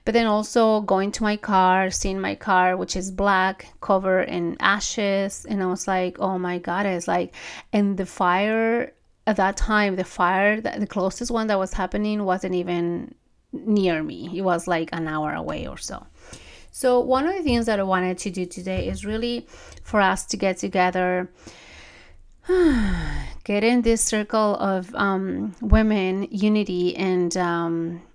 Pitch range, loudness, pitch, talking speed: 180-215 Hz, -23 LUFS, 195 Hz, 170 wpm